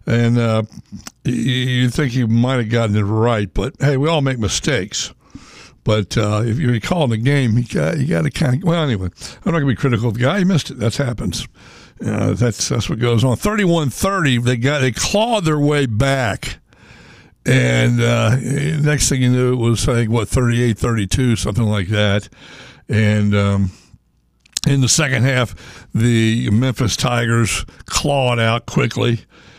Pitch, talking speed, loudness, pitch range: 120 Hz, 180 wpm, -17 LUFS, 110-135 Hz